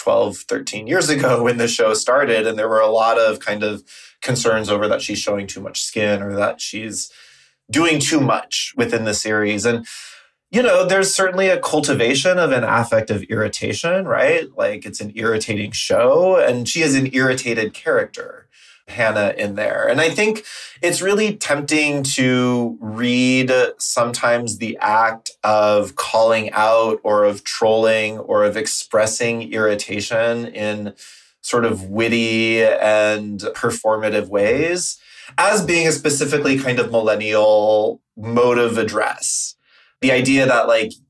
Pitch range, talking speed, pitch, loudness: 105-135 Hz, 150 wpm, 115 Hz, -17 LUFS